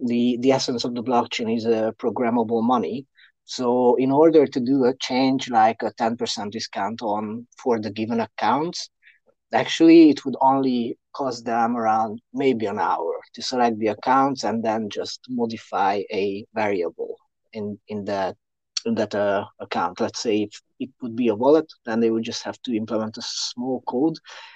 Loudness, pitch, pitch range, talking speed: -22 LUFS, 120 Hz, 110-135 Hz, 180 wpm